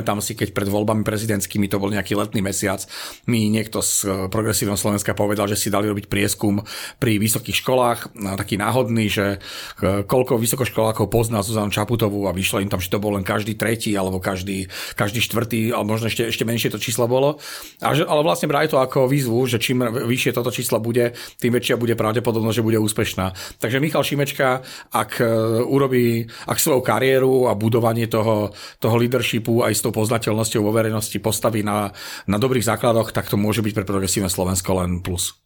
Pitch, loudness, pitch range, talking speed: 110 Hz, -20 LUFS, 105-120 Hz, 185 wpm